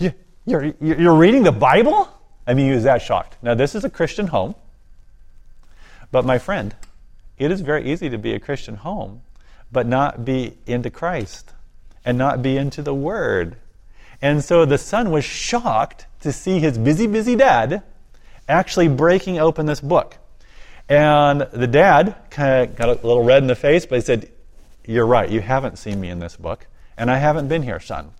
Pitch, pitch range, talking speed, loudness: 135 Hz, 115-155 Hz, 185 wpm, -18 LUFS